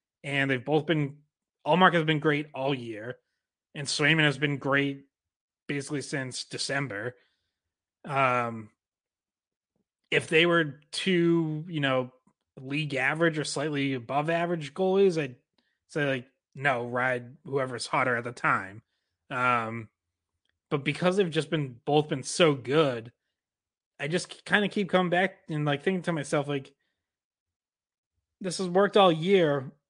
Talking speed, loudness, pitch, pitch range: 140 wpm, -27 LUFS, 145 Hz, 130-165 Hz